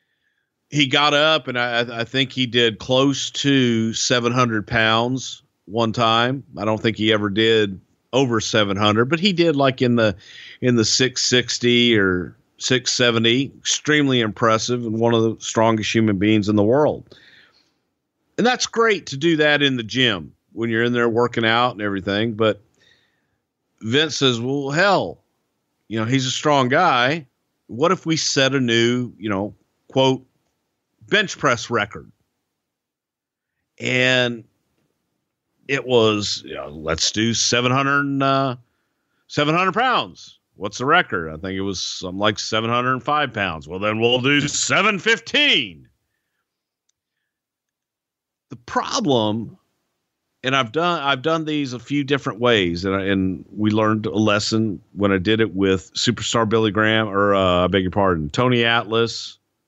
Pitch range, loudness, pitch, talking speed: 110-135 Hz, -19 LUFS, 120 Hz, 150 wpm